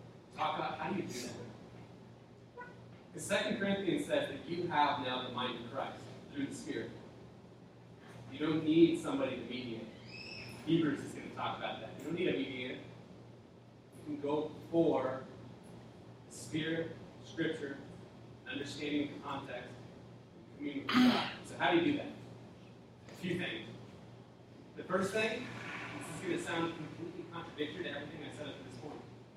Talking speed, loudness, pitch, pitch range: 160 wpm, -37 LUFS, 150 Hz, 125-170 Hz